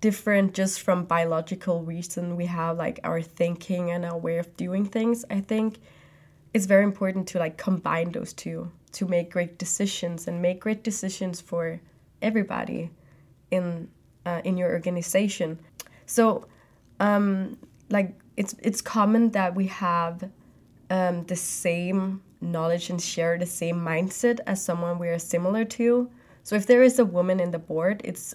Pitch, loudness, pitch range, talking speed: 180 Hz, -26 LUFS, 170-200 Hz, 160 wpm